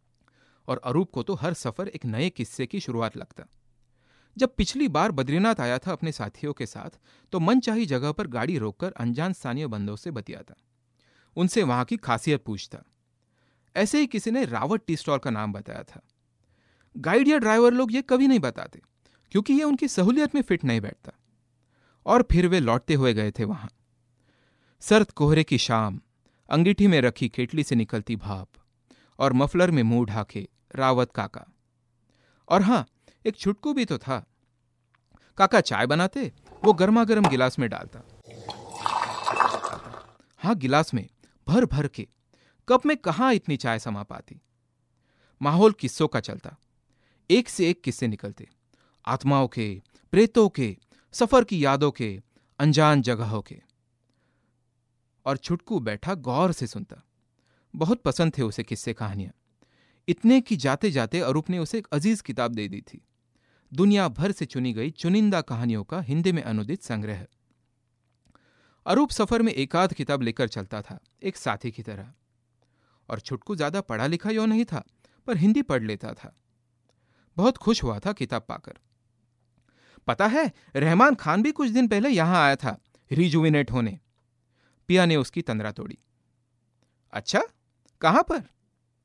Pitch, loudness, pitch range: 130 Hz, -24 LUFS, 120-185 Hz